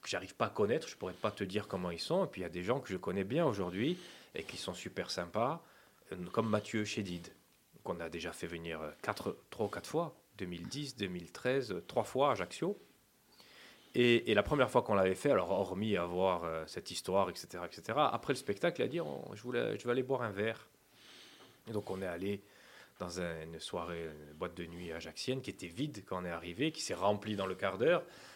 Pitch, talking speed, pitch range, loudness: 100 Hz, 220 wpm, 90-115 Hz, -37 LUFS